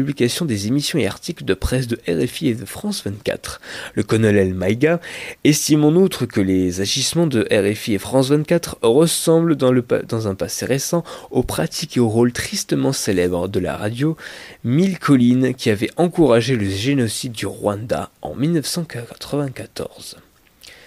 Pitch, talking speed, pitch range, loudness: 125 Hz, 160 wpm, 105-155 Hz, -19 LUFS